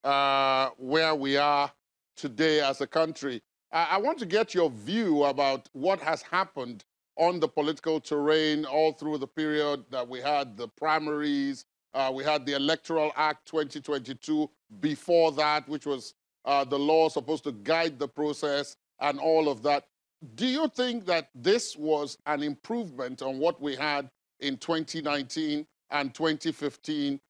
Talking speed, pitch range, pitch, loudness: 155 wpm, 140-160 Hz, 150 Hz, -28 LUFS